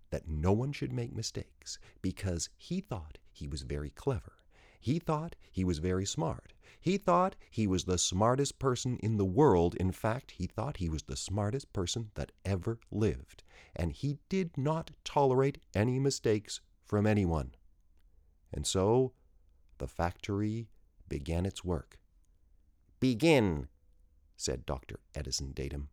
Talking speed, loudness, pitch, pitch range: 145 wpm, -33 LUFS, 95 Hz, 75-120 Hz